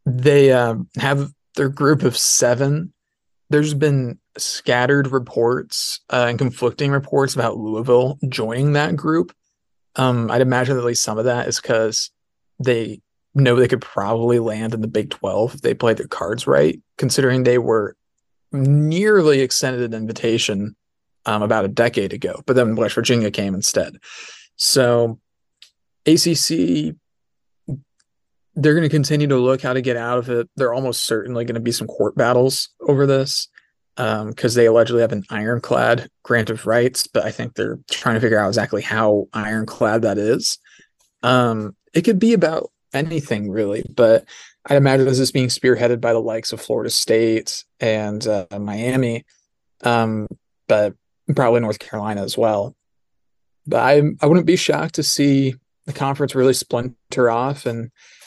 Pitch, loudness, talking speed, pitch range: 125 Hz, -18 LUFS, 160 wpm, 110-140 Hz